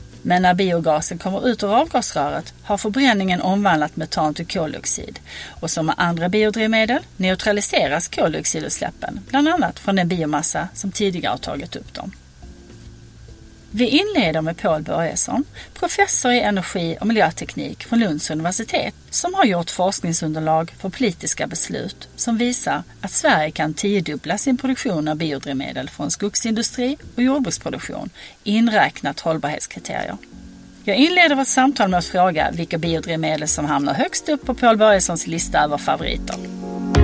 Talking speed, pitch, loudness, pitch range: 140 wpm, 195 Hz, -18 LUFS, 160-235 Hz